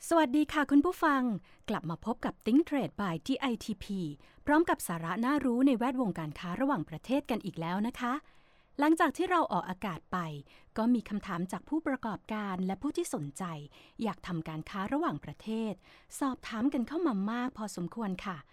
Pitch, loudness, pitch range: 220 Hz, -33 LUFS, 180-275 Hz